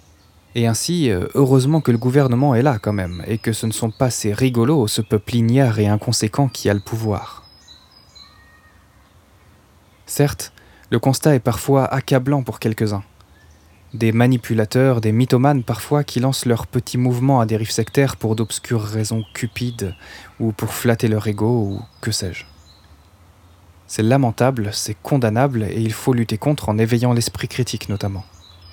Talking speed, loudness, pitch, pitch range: 155 wpm, -19 LUFS, 110 Hz, 100-125 Hz